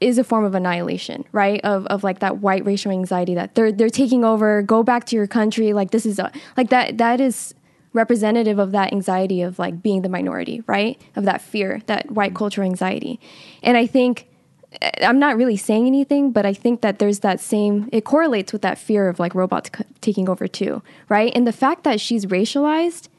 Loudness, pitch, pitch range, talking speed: -19 LUFS, 215 Hz, 195-240 Hz, 210 wpm